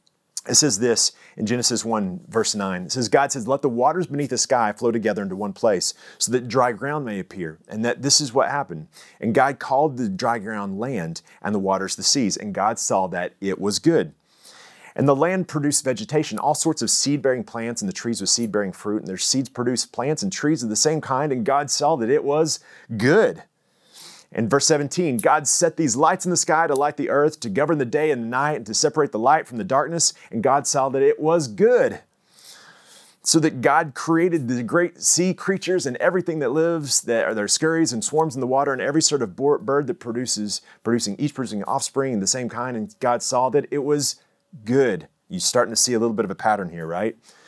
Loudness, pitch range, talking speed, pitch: -21 LUFS, 115-155 Hz, 230 wpm, 135 Hz